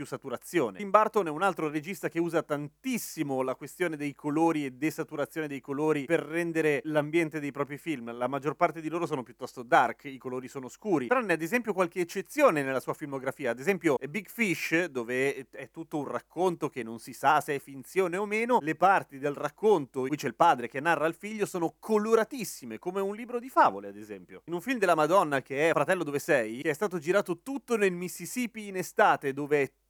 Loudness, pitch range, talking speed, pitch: -29 LUFS, 140-185 Hz, 215 wpm, 155 Hz